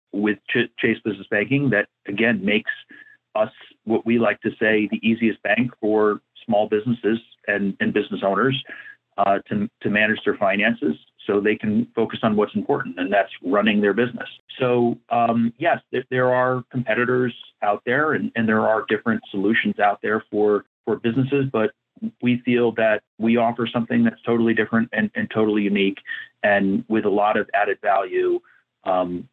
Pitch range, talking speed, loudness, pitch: 105-125 Hz, 170 wpm, -21 LUFS, 115 Hz